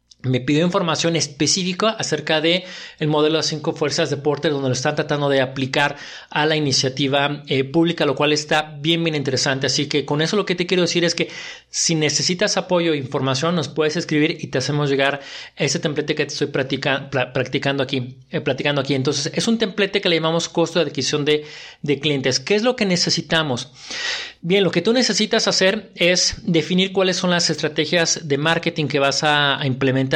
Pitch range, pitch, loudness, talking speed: 145-170 Hz, 155 Hz, -19 LUFS, 200 wpm